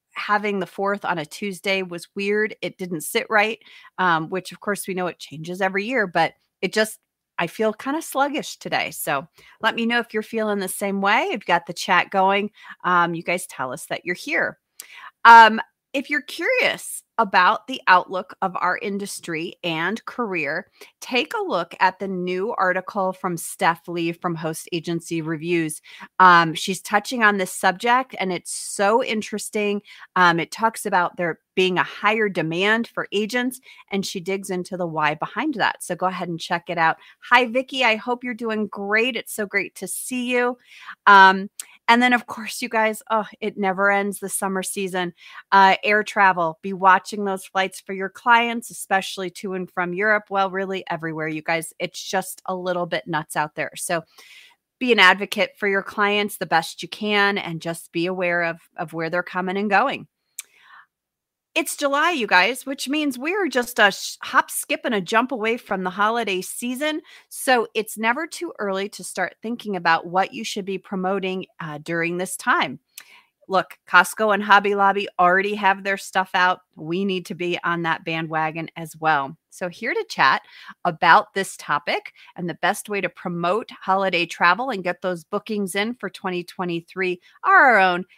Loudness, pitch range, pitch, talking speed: -21 LUFS, 180-220 Hz, 195 Hz, 185 wpm